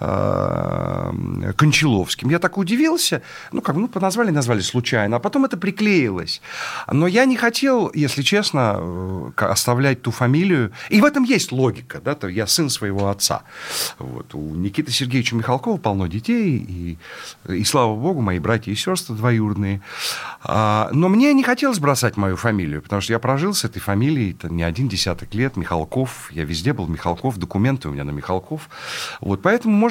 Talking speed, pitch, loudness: 165 wpm, 125 Hz, -20 LUFS